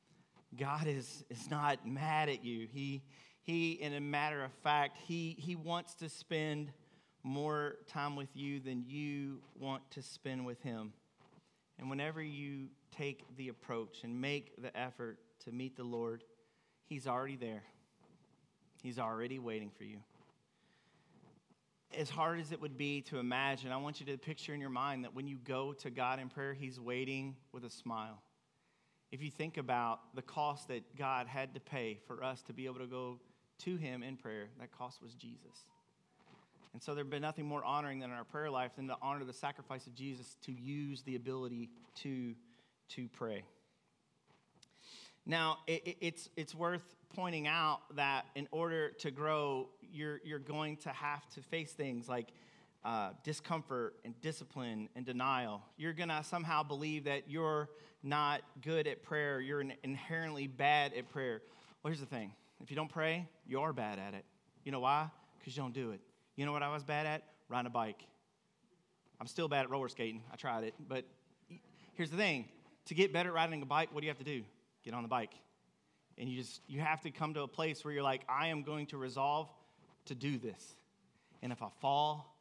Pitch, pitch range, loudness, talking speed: 140 Hz, 125-155 Hz, -41 LUFS, 190 wpm